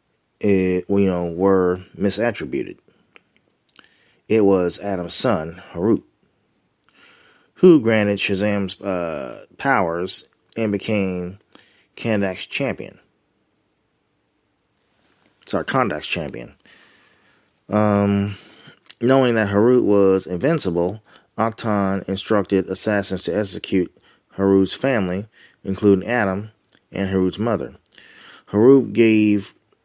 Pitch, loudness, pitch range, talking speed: 100 Hz, -20 LUFS, 95-105 Hz, 85 wpm